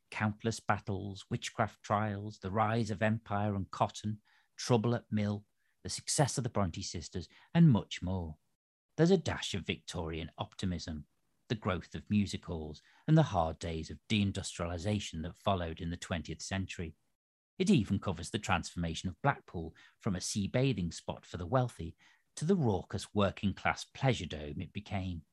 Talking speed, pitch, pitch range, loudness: 165 wpm, 100 Hz, 85-110 Hz, -35 LUFS